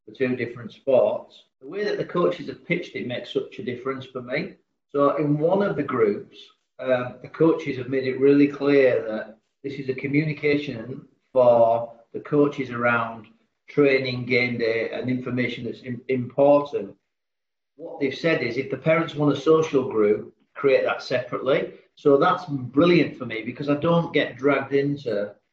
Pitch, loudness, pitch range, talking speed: 135 Hz, -23 LUFS, 125-145 Hz, 175 wpm